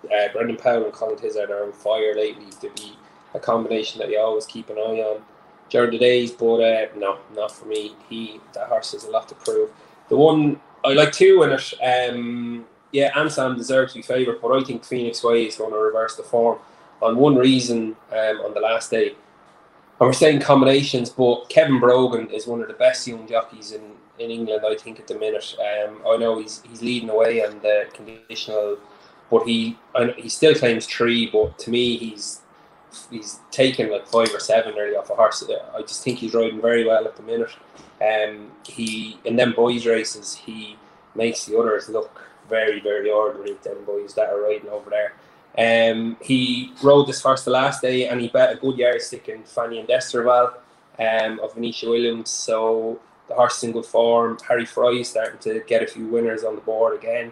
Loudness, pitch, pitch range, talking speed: -20 LUFS, 115 Hz, 110-130 Hz, 205 wpm